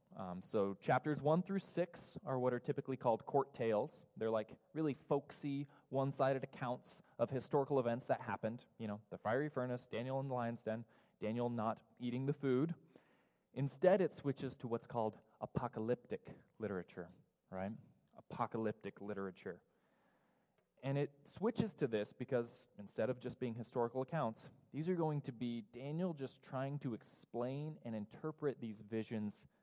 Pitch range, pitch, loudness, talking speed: 115-145 Hz, 125 Hz, -41 LUFS, 155 wpm